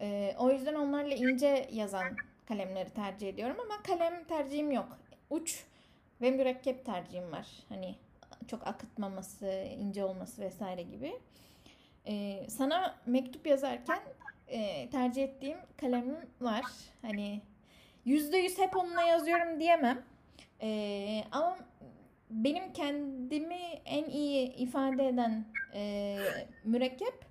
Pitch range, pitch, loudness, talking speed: 210-295 Hz, 260 Hz, -35 LUFS, 110 wpm